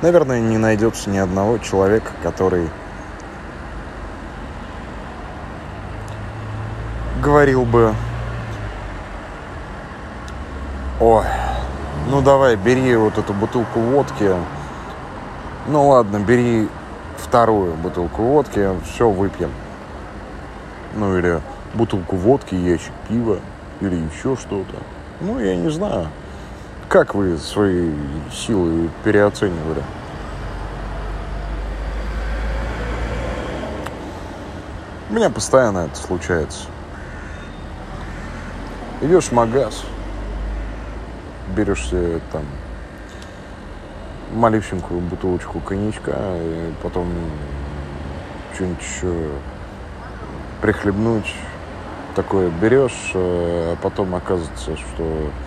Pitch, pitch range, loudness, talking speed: 90 Hz, 75-105 Hz, -20 LUFS, 75 wpm